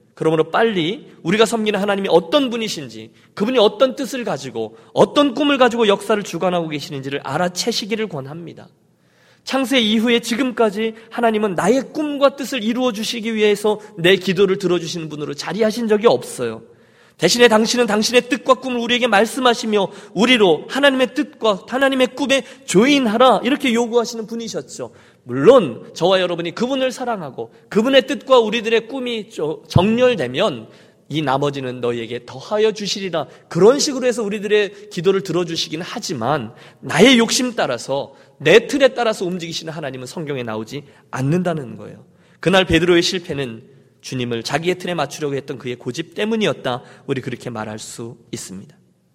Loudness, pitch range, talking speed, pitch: -18 LUFS, 160-240 Hz, 380 characters per minute, 210 Hz